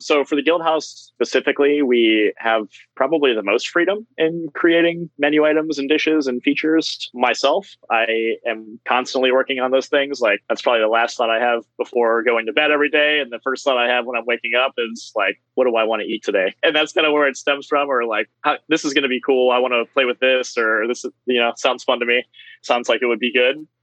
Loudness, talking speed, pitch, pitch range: -18 LUFS, 245 wpm, 130 Hz, 120-150 Hz